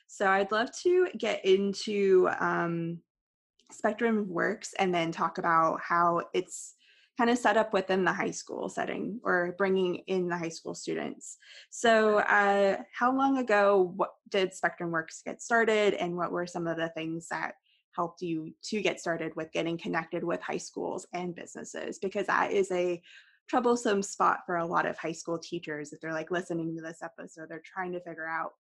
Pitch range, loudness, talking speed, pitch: 165-205 Hz, -29 LUFS, 185 wpm, 180 Hz